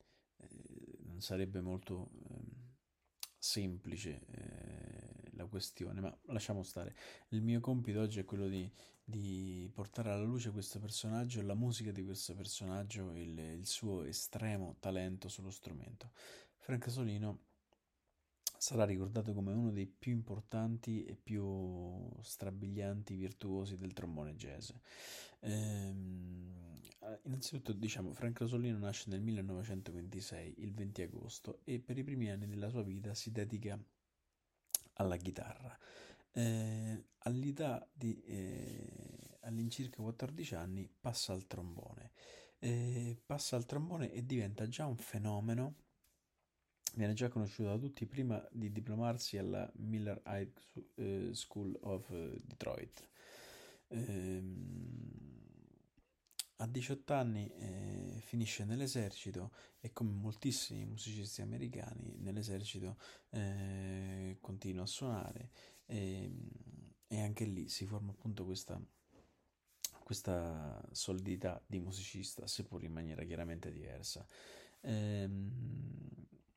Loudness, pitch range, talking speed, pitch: -43 LUFS, 95-120 Hz, 110 wpm, 105 Hz